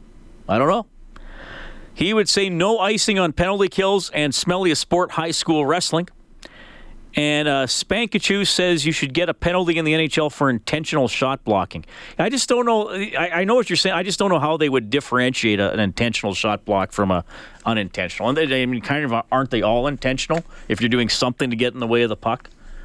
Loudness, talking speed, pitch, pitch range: -20 LUFS, 220 wpm, 155 Hz, 125-180 Hz